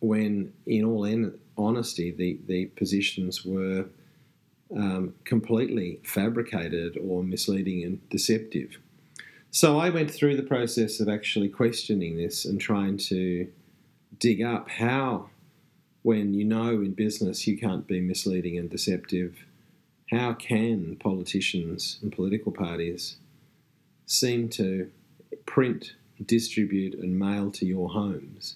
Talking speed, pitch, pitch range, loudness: 120 wpm, 105 Hz, 95-115 Hz, -28 LUFS